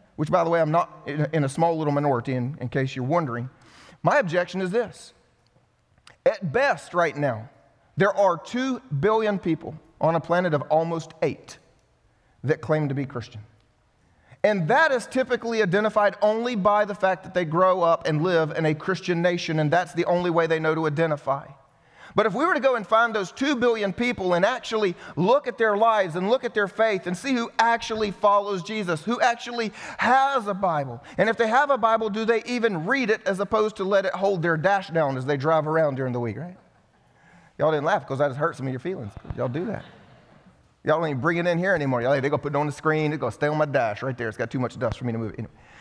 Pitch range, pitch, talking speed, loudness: 145-210 Hz, 175 Hz, 235 wpm, -24 LUFS